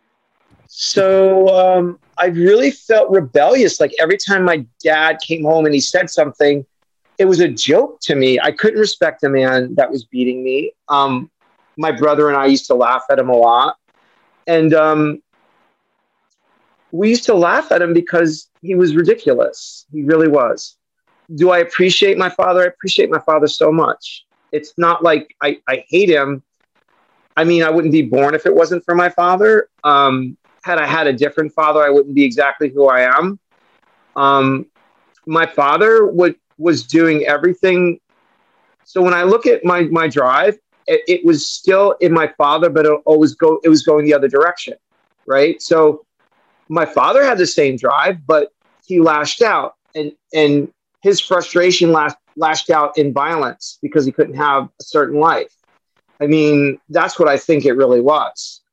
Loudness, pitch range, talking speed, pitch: -14 LUFS, 145-180 Hz, 175 wpm, 160 Hz